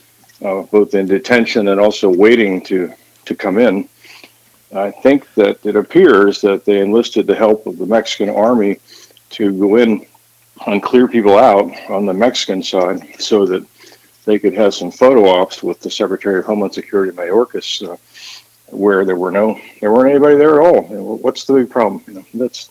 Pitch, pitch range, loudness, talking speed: 105 Hz, 100-120 Hz, -13 LUFS, 180 wpm